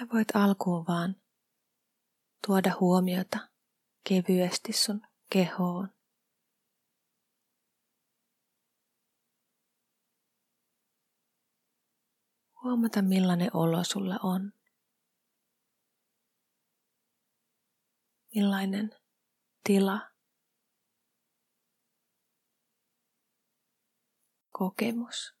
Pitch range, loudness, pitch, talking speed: 185-225 Hz, -29 LUFS, 195 Hz, 40 wpm